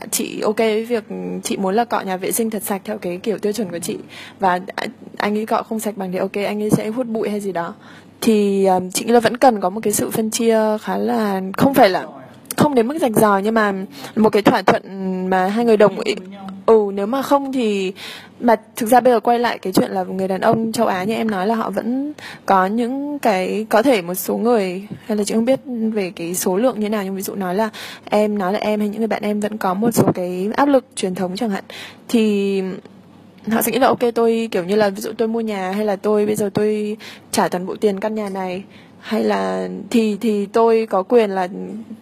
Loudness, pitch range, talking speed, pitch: -18 LUFS, 195-230 Hz, 255 wpm, 215 Hz